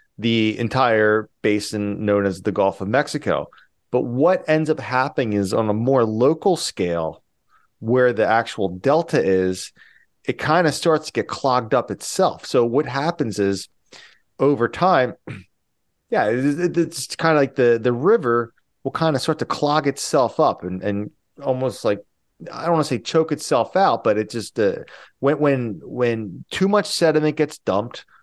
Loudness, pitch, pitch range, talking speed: -20 LUFS, 120 Hz, 105-150 Hz, 170 wpm